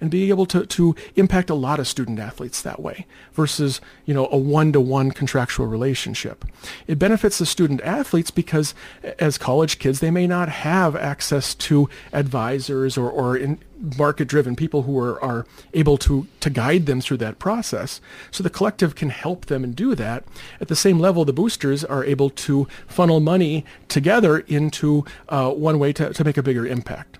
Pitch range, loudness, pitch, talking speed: 135-170 Hz, -20 LUFS, 150 Hz, 185 wpm